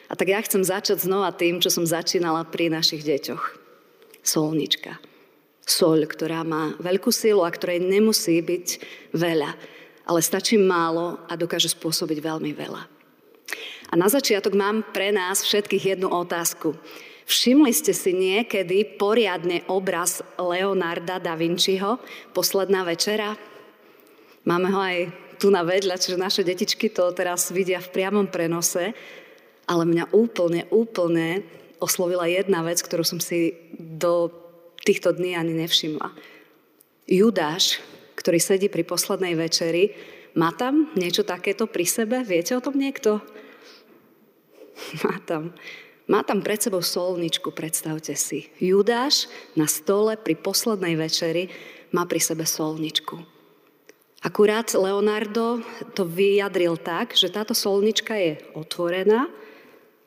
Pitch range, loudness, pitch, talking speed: 170-215 Hz, -23 LUFS, 185 Hz, 125 wpm